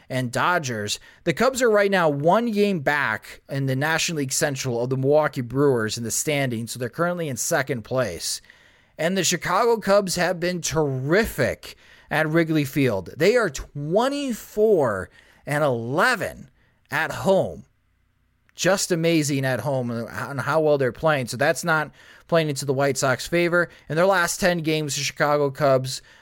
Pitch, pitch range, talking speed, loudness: 150 Hz, 130-175 Hz, 165 wpm, -22 LUFS